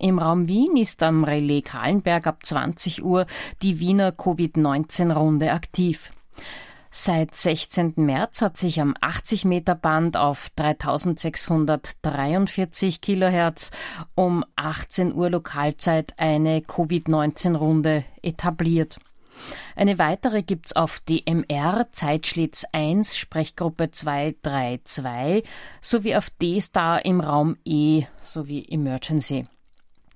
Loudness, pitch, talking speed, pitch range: -23 LUFS, 165 Hz, 100 wpm, 150-180 Hz